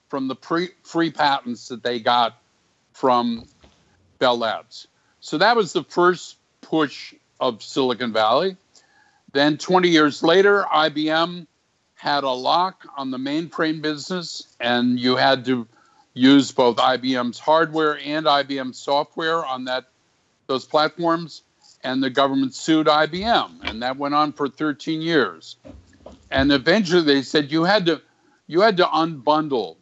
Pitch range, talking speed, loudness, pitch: 130-165 Hz, 140 wpm, -20 LUFS, 150 Hz